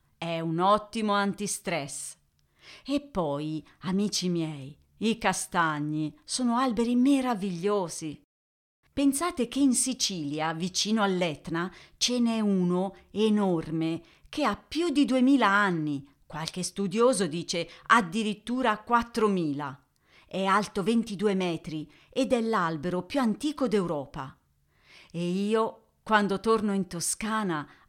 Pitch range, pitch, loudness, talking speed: 165-225 Hz, 195 Hz, -28 LUFS, 110 wpm